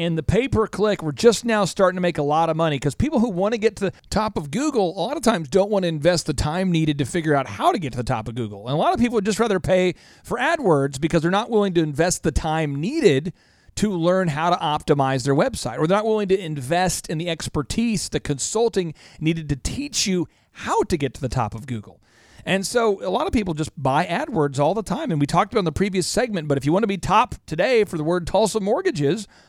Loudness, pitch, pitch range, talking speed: -21 LUFS, 170 Hz, 145-200 Hz, 270 wpm